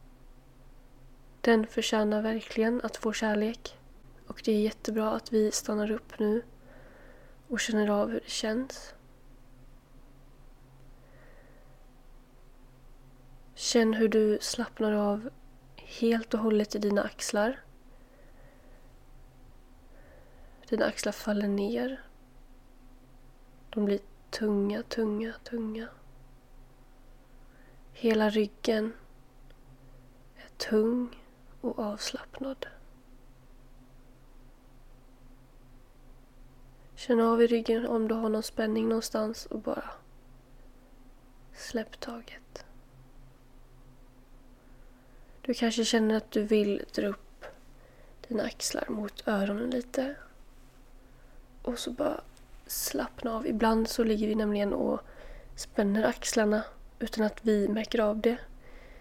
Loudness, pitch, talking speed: -30 LUFS, 205 Hz, 95 wpm